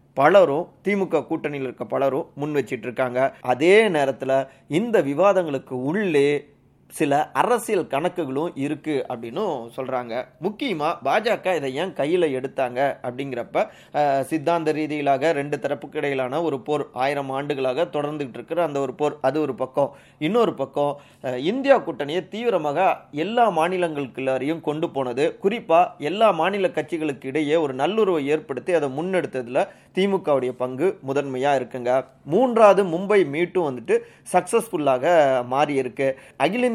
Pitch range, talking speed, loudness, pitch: 135-170 Hz, 120 wpm, -22 LUFS, 145 Hz